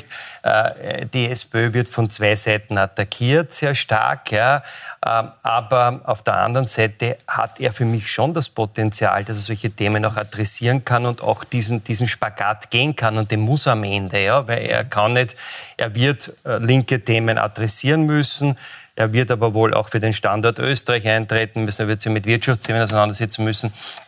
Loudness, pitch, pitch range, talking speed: -19 LUFS, 115 Hz, 110-125 Hz, 175 wpm